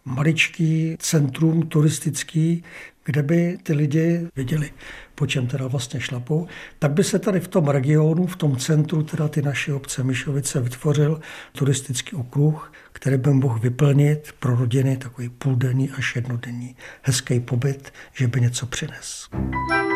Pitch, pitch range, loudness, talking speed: 145 Hz, 130-155 Hz, -22 LUFS, 140 wpm